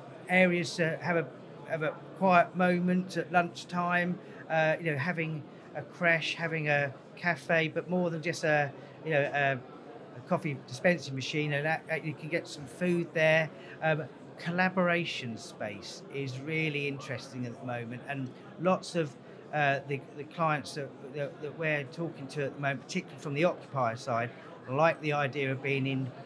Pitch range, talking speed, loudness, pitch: 140-170 Hz, 170 wpm, -31 LUFS, 155 Hz